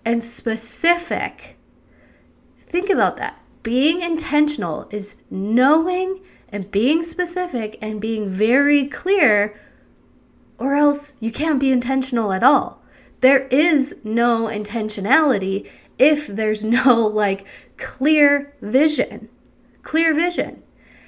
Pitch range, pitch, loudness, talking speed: 220-300 Hz, 260 Hz, -19 LUFS, 105 wpm